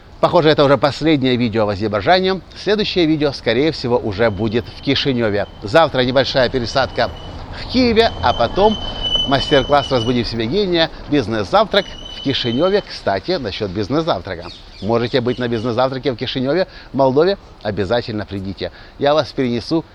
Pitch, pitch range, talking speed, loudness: 130 Hz, 110-150 Hz, 135 wpm, -17 LUFS